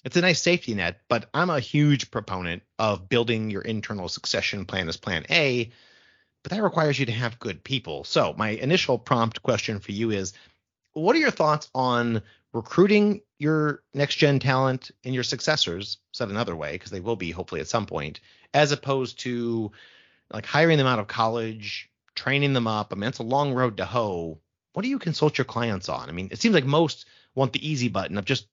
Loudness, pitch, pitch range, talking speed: -25 LUFS, 120 Hz, 105-145 Hz, 205 wpm